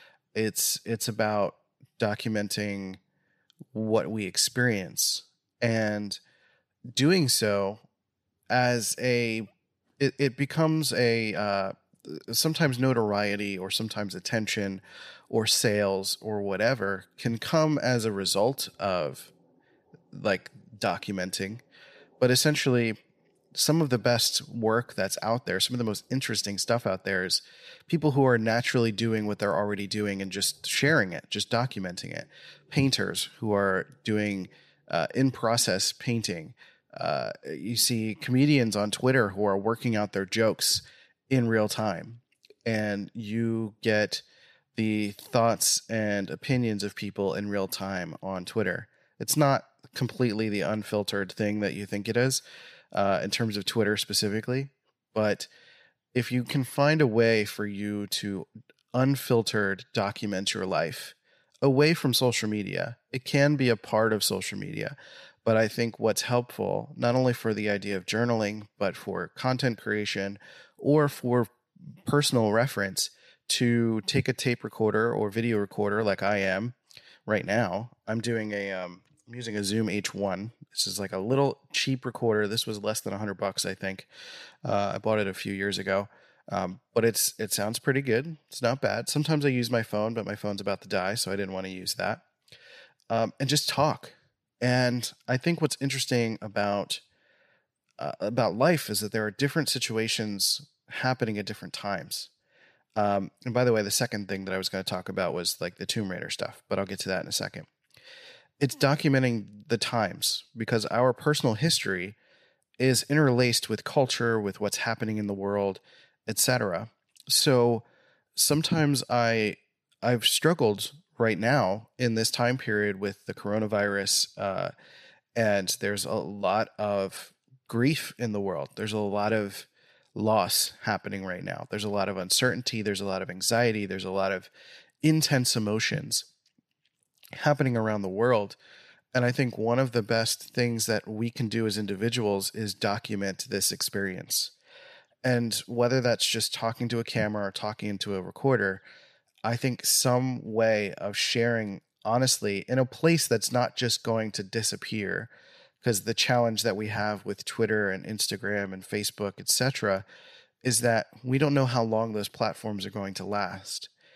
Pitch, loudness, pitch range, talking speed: 110 Hz, -27 LUFS, 100-125 Hz, 160 wpm